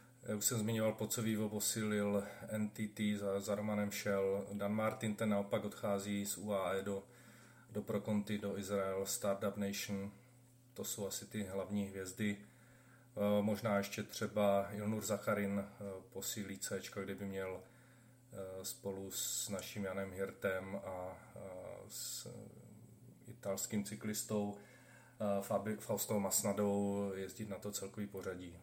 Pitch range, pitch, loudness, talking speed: 100-110 Hz, 105 Hz, -40 LUFS, 115 wpm